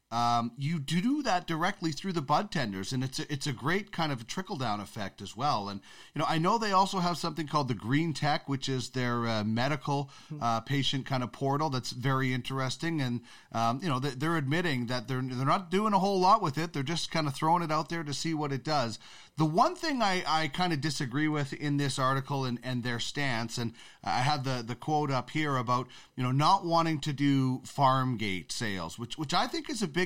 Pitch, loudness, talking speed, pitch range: 145 Hz, -30 LUFS, 235 wpm, 125-165 Hz